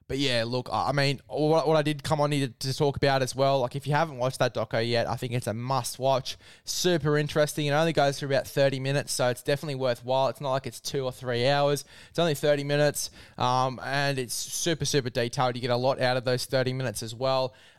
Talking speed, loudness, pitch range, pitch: 245 wpm, -27 LUFS, 125-145 Hz, 135 Hz